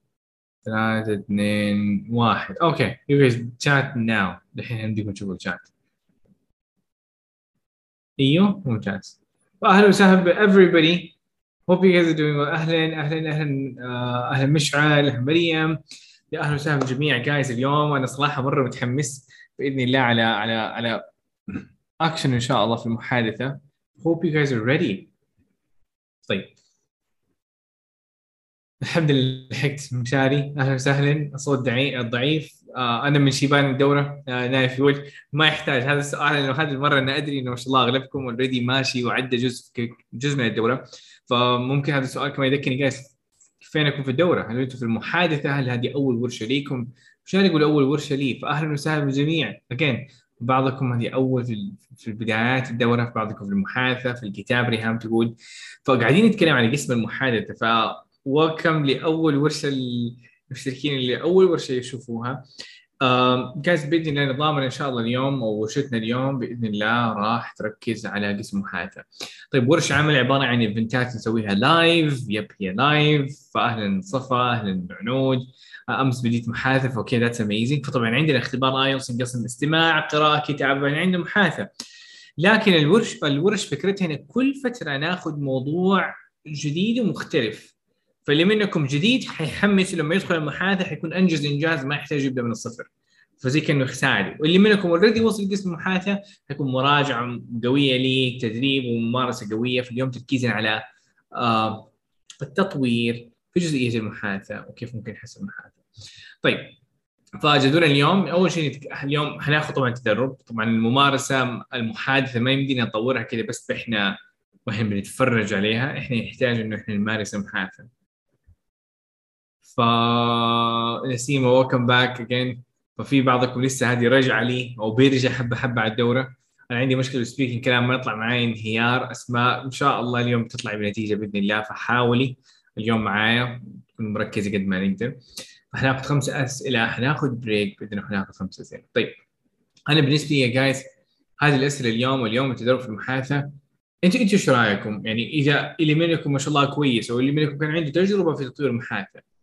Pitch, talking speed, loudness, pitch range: 130 Hz, 140 wpm, -21 LUFS, 120-150 Hz